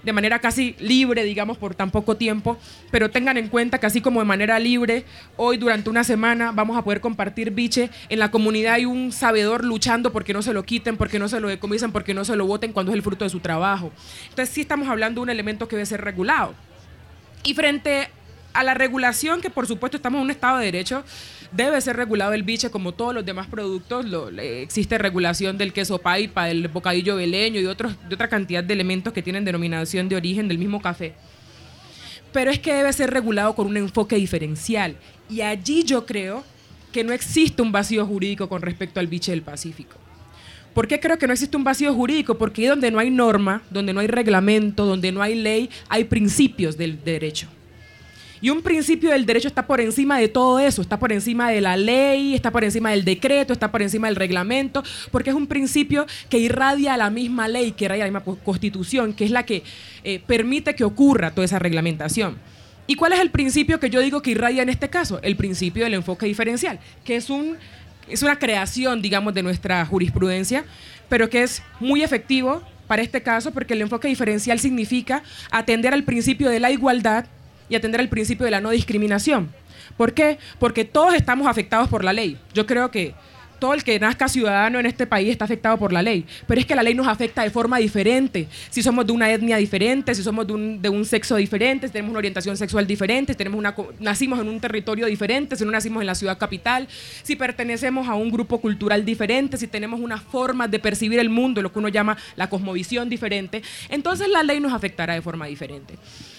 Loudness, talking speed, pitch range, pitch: -21 LUFS, 215 wpm, 200-250 Hz, 225 Hz